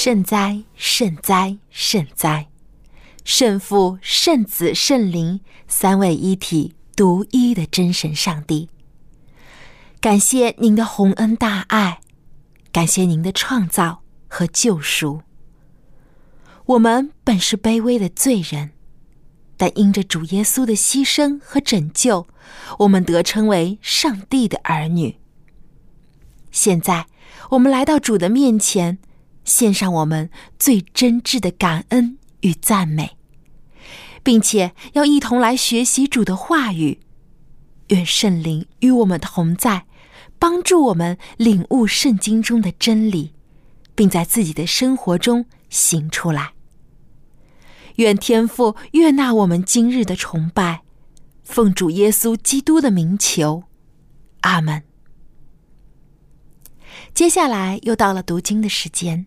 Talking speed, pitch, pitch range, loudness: 175 characters per minute, 190 Hz, 160-230 Hz, -17 LUFS